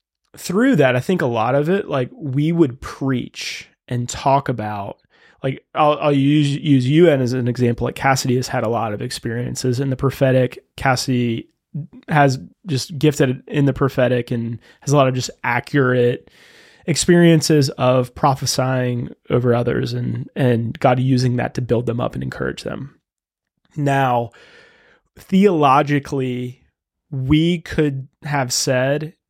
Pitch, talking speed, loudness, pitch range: 135 Hz, 145 wpm, -18 LUFS, 125-150 Hz